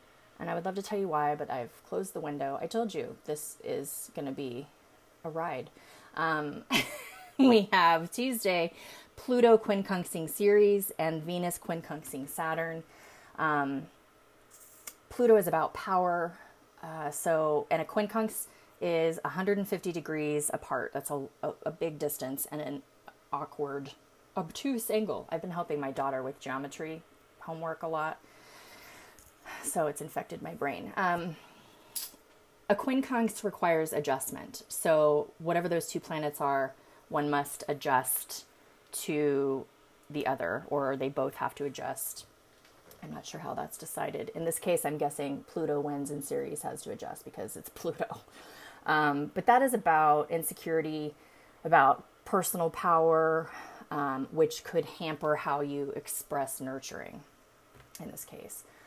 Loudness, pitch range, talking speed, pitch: -31 LUFS, 145-180 Hz, 140 wpm, 160 Hz